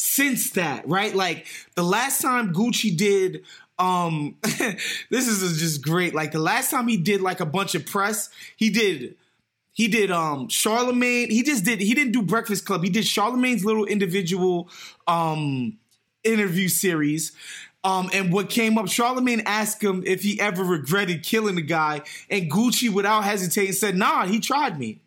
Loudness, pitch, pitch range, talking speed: -22 LUFS, 200 Hz, 180-225 Hz, 170 wpm